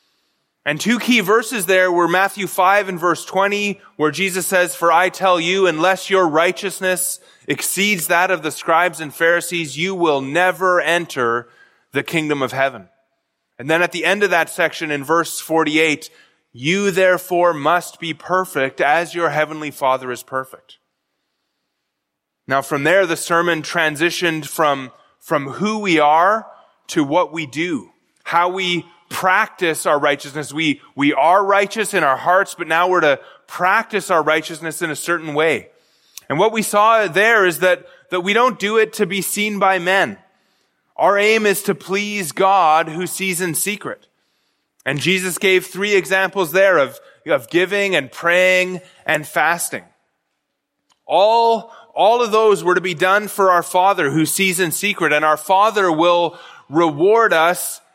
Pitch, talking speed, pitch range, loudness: 180 Hz, 165 wpm, 160-195 Hz, -17 LUFS